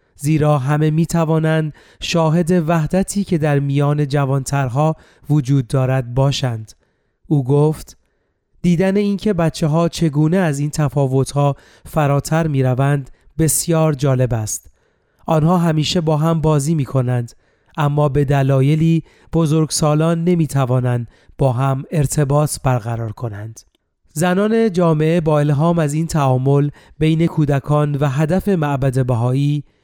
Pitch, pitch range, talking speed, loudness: 150 Hz, 135-160 Hz, 125 wpm, -17 LUFS